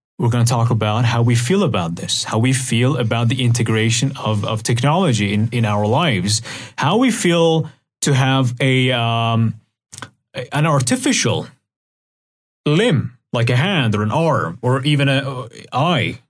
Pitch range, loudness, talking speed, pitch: 115-140 Hz, -17 LUFS, 160 wpm, 125 Hz